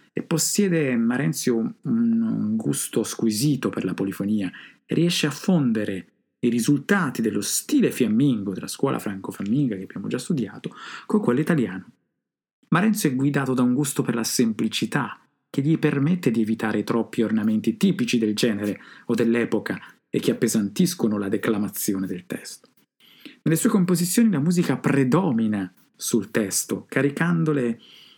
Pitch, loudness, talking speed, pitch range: 130 Hz, -23 LUFS, 140 wpm, 110-165 Hz